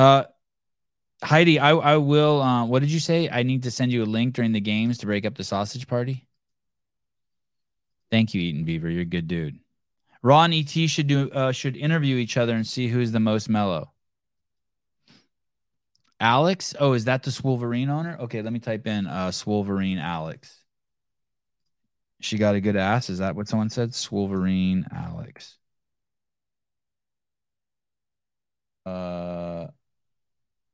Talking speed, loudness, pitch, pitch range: 150 wpm, -23 LUFS, 120 Hz, 100-135 Hz